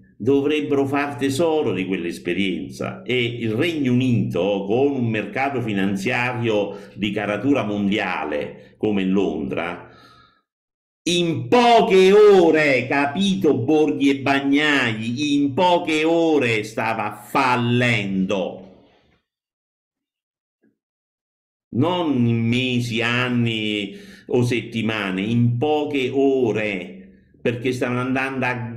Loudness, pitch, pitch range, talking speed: -20 LUFS, 125 Hz, 105-140 Hz, 90 wpm